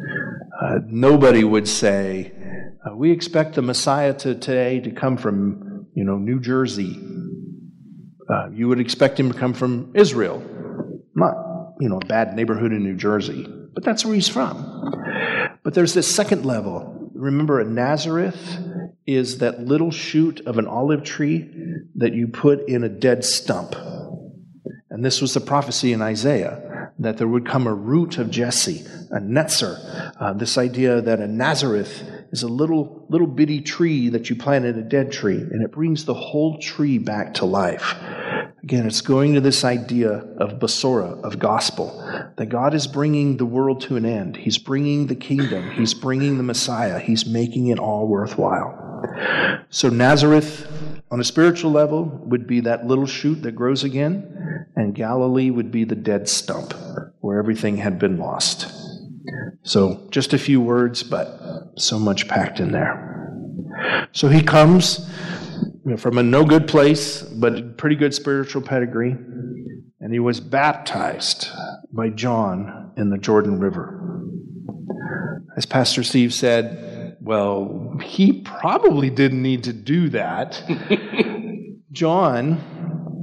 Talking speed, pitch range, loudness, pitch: 155 wpm, 120-160 Hz, -20 LUFS, 135 Hz